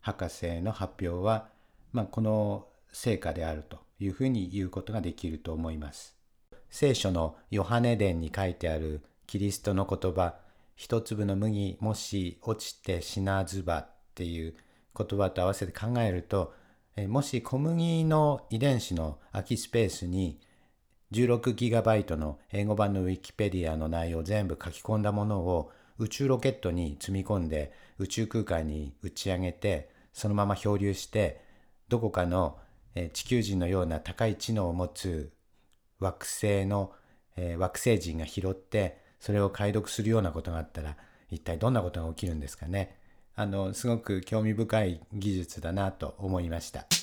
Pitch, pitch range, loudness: 95 Hz, 85-110 Hz, -31 LUFS